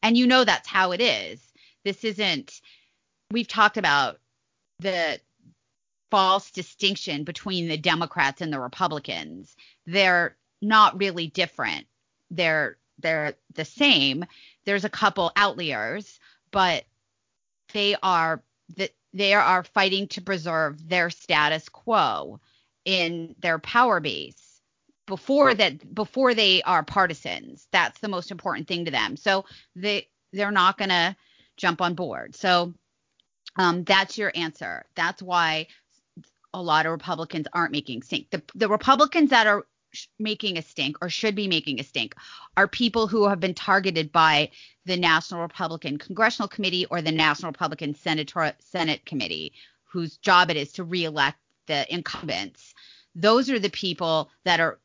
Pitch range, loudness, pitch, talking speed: 160-205 Hz, -23 LUFS, 180 Hz, 145 wpm